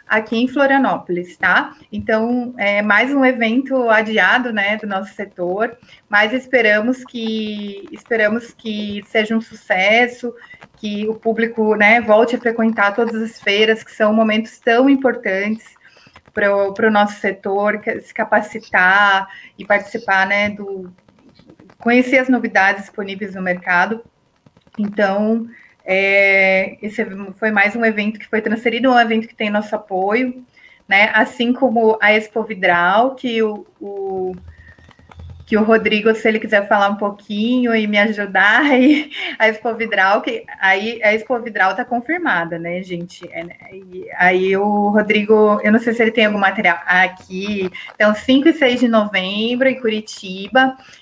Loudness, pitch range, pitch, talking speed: -16 LUFS, 200-230 Hz, 215 Hz, 150 wpm